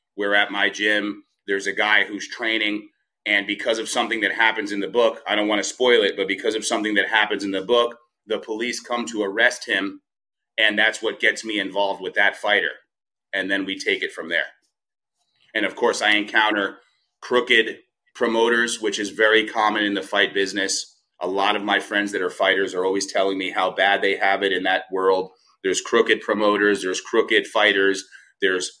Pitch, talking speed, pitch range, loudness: 105 Hz, 200 wpm, 95-110 Hz, -21 LUFS